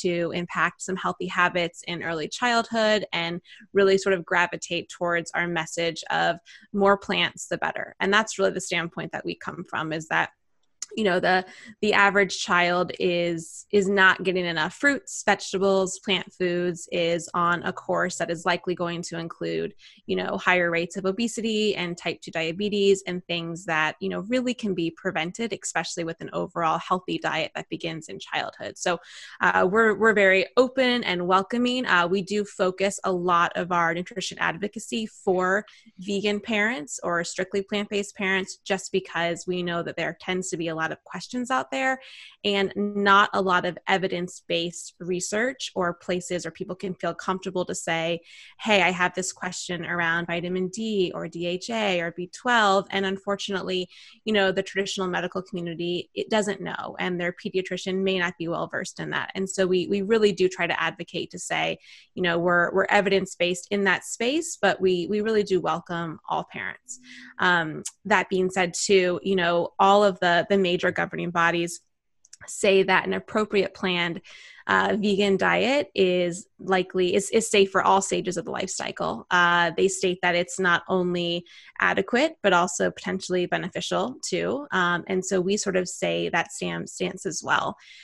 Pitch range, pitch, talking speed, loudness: 175-200 Hz, 185 Hz, 180 wpm, -25 LUFS